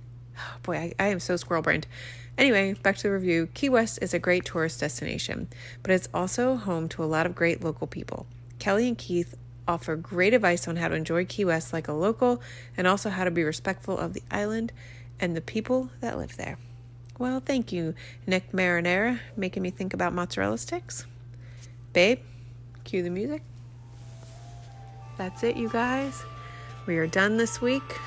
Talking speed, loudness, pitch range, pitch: 180 wpm, -27 LUFS, 120-190 Hz, 165 Hz